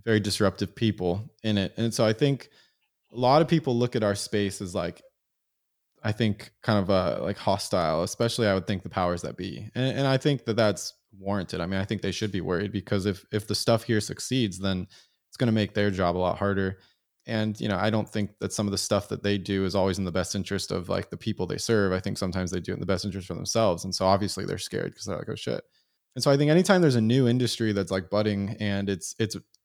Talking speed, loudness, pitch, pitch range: 260 wpm, -27 LUFS, 105 Hz, 95-115 Hz